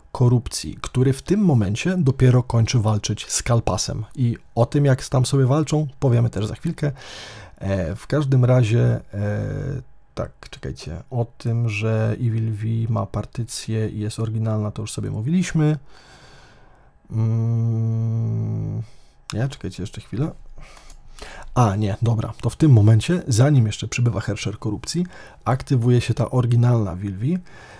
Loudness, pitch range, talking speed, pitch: -21 LUFS, 110-130 Hz, 135 wpm, 115 Hz